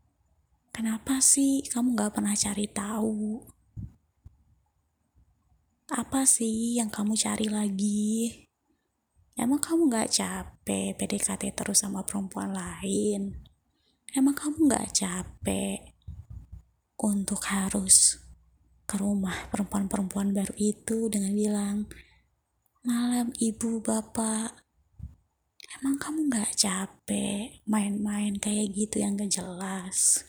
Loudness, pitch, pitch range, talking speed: -27 LUFS, 210 Hz, 190-225 Hz, 95 wpm